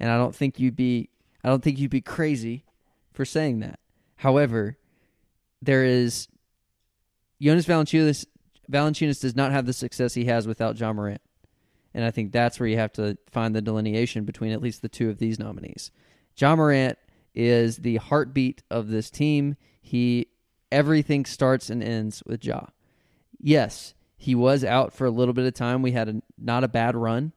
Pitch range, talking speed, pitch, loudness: 110-135 Hz, 180 wpm, 120 Hz, -24 LUFS